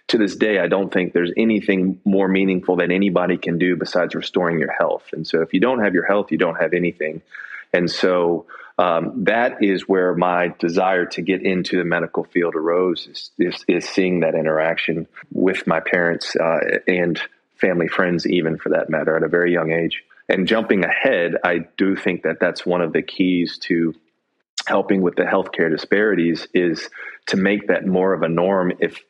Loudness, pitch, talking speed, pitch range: -19 LUFS, 90 Hz, 195 wpm, 85-95 Hz